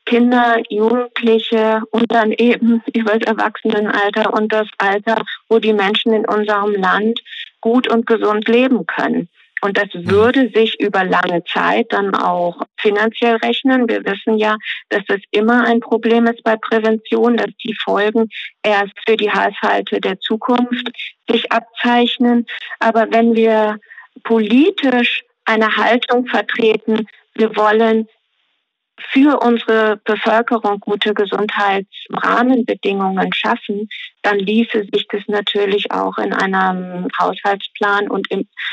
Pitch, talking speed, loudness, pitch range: 220 Hz, 125 wpm, -15 LUFS, 210-230 Hz